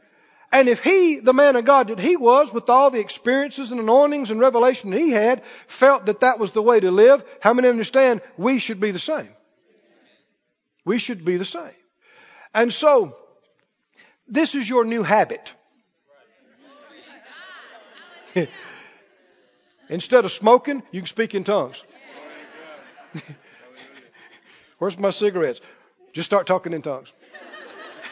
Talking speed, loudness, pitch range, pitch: 140 wpm, -19 LUFS, 210-295 Hz, 250 Hz